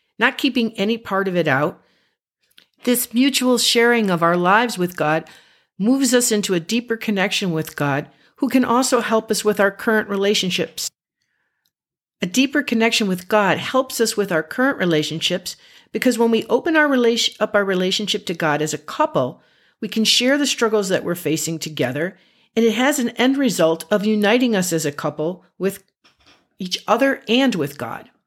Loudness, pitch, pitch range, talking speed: -19 LUFS, 215 Hz, 180-240 Hz, 180 wpm